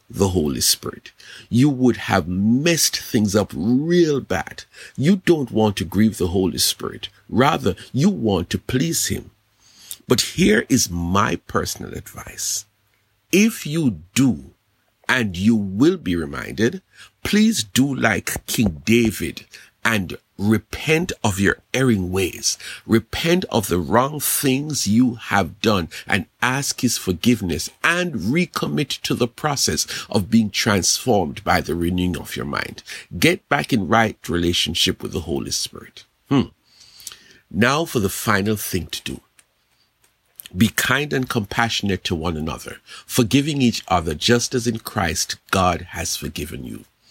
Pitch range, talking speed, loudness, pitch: 95-130 Hz, 140 wpm, -20 LUFS, 110 Hz